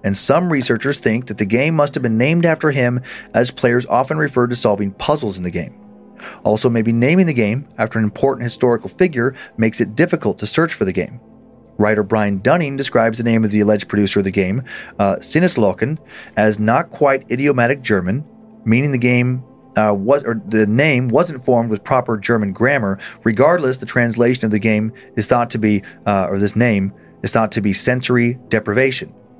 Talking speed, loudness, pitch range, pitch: 195 wpm, -17 LUFS, 105-130 Hz, 120 Hz